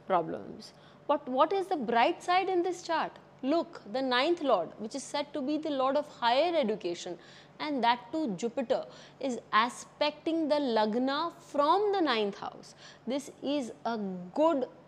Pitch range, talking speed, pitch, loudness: 235-315 Hz, 160 wpm, 280 Hz, -30 LUFS